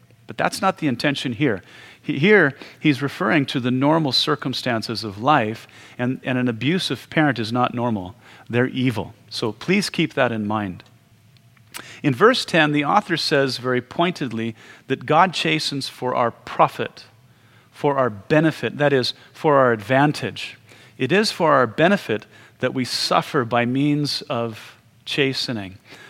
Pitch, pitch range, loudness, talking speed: 125 Hz, 120-145 Hz, -20 LUFS, 150 wpm